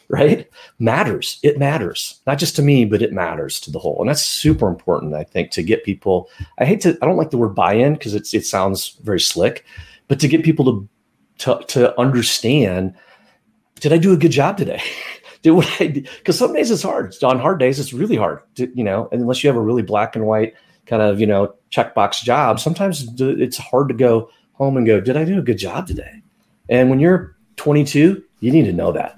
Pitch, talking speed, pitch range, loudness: 130 Hz, 225 wpm, 110-150 Hz, -17 LUFS